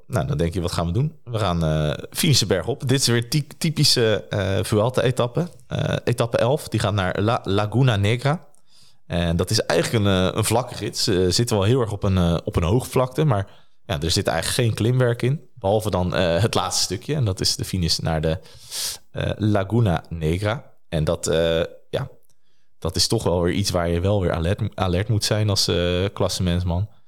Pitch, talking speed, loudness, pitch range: 105 Hz, 205 wpm, -22 LUFS, 90-120 Hz